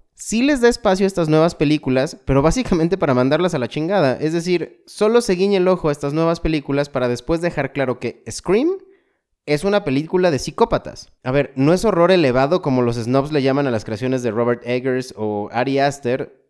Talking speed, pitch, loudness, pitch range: 205 wpm, 150 Hz, -18 LUFS, 130-180 Hz